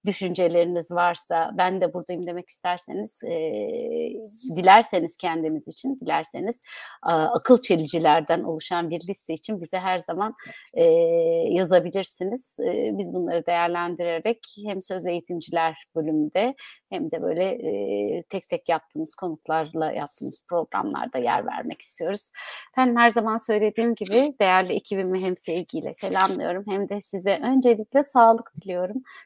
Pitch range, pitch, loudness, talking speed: 170-230 Hz, 185 Hz, -24 LUFS, 125 wpm